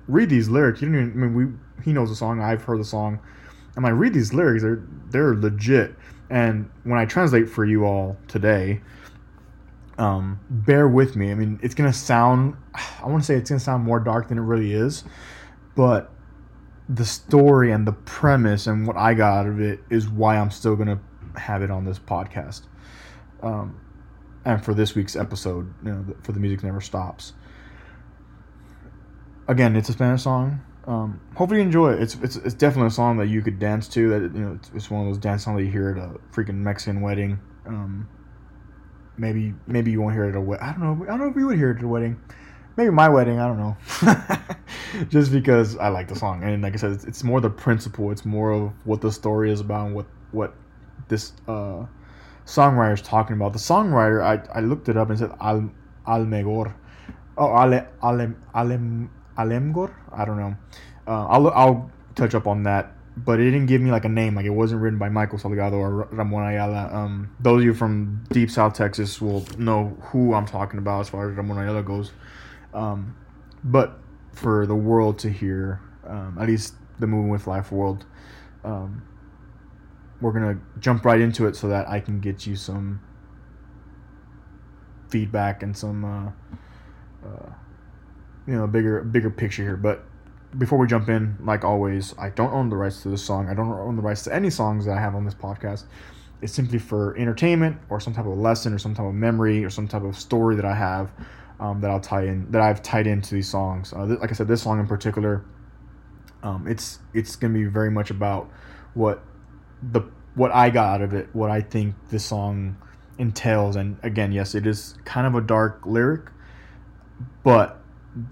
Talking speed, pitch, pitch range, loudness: 205 wpm, 110 Hz, 100-115 Hz, -22 LUFS